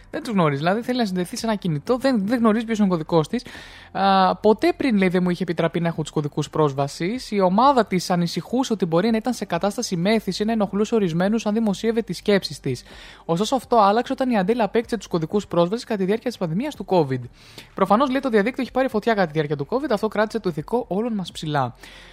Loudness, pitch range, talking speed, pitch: -22 LUFS, 175-230 Hz, 220 wpm, 205 Hz